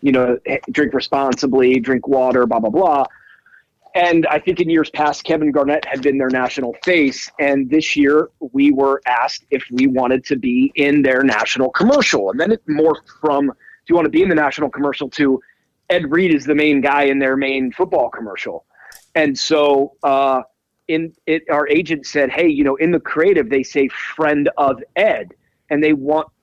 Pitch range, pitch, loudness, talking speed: 135-155 Hz, 145 Hz, -16 LUFS, 195 wpm